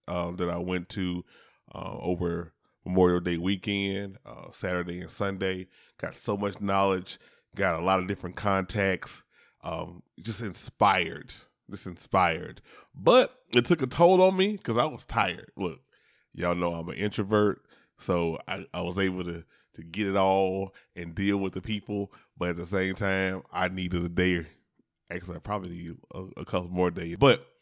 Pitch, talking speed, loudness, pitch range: 95 Hz, 175 wpm, -28 LUFS, 90-100 Hz